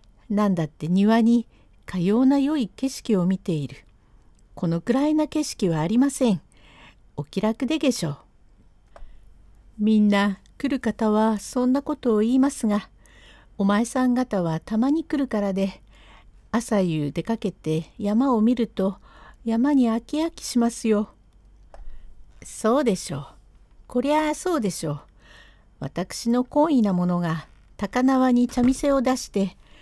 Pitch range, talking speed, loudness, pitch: 175-255 Hz, 255 characters per minute, -23 LUFS, 215 Hz